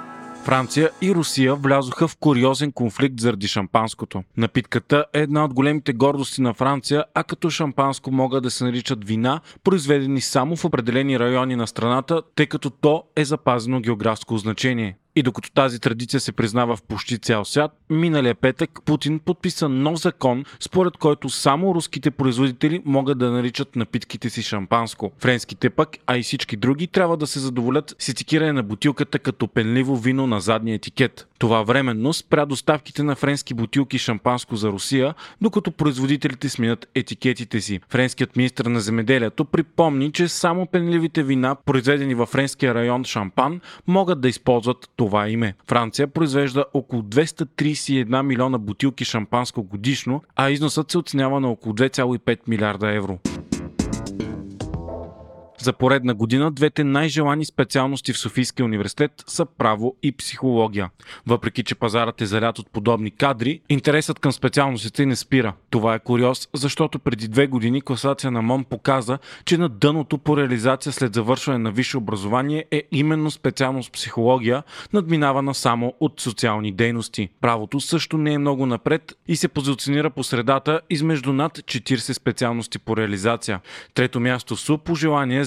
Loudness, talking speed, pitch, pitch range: -21 LUFS, 150 wpm, 130 Hz, 120-145 Hz